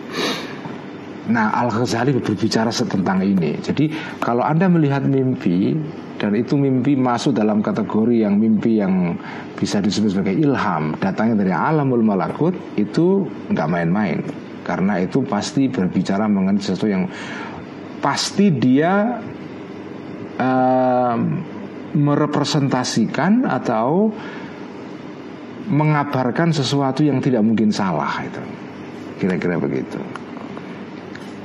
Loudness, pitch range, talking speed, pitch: -19 LUFS, 115-155 Hz, 100 wpm, 135 Hz